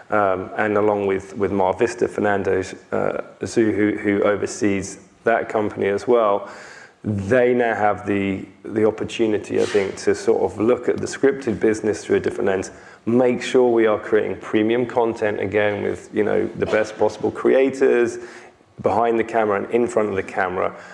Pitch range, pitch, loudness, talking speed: 100-120 Hz, 110 Hz, -20 LUFS, 170 wpm